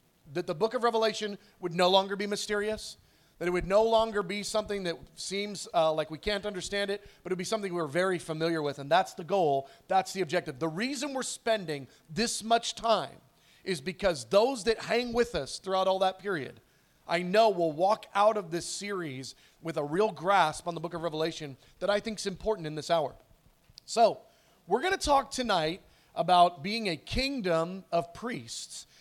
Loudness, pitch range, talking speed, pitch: -30 LUFS, 165-215 Hz, 195 wpm, 190 Hz